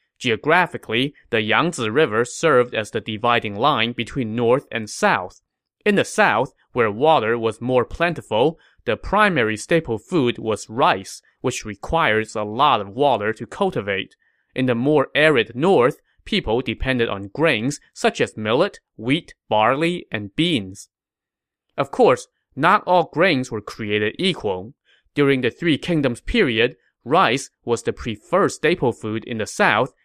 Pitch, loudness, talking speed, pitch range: 120 Hz, -20 LUFS, 145 wpm, 110-150 Hz